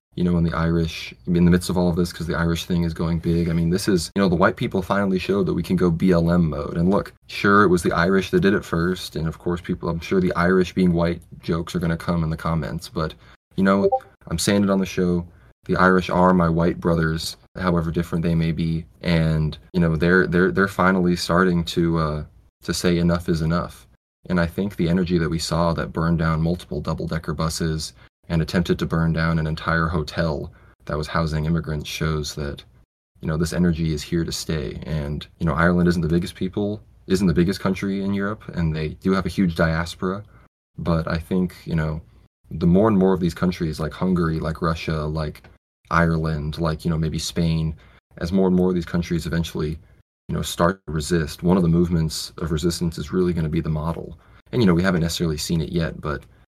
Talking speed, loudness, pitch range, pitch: 225 wpm, -22 LUFS, 80-90 Hz, 85 Hz